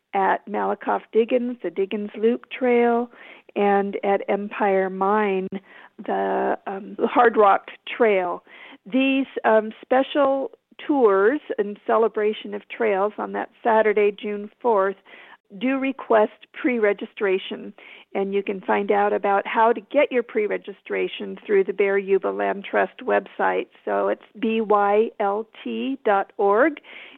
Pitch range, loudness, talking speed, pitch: 200-235 Hz, -22 LUFS, 125 wpm, 215 Hz